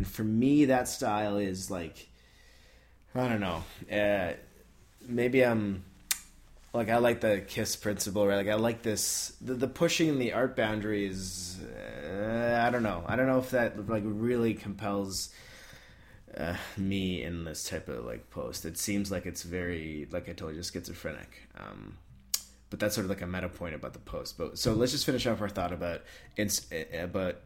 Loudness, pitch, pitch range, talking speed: -31 LUFS, 100 Hz, 90-115 Hz, 185 wpm